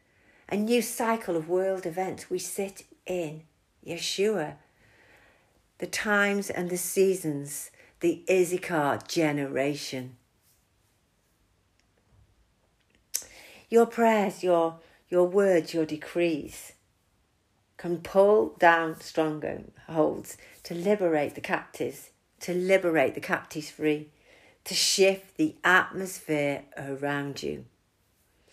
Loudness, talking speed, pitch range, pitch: -27 LUFS, 95 wpm, 145-190 Hz, 165 Hz